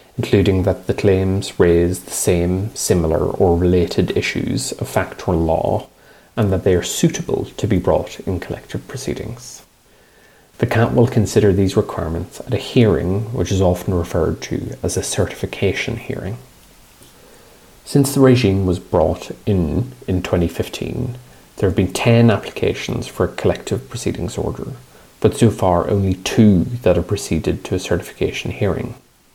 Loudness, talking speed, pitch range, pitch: -18 LUFS, 150 wpm, 90-115 Hz, 100 Hz